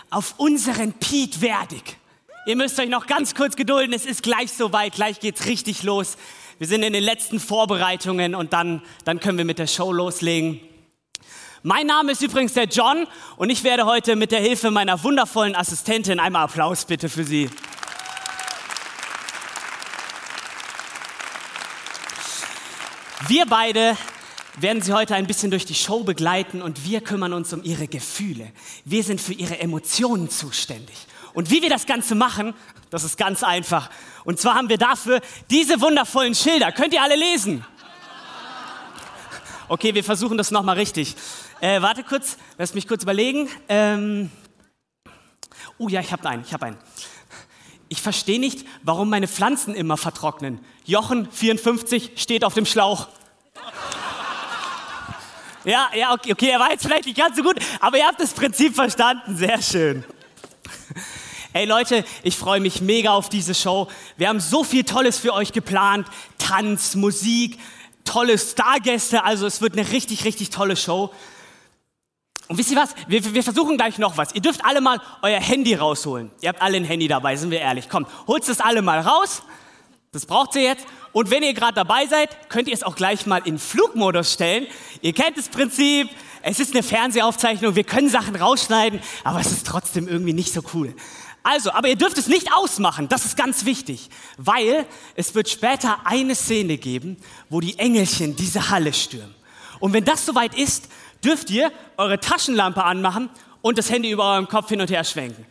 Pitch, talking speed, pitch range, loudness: 215 Hz, 170 wpm, 185-250 Hz, -20 LUFS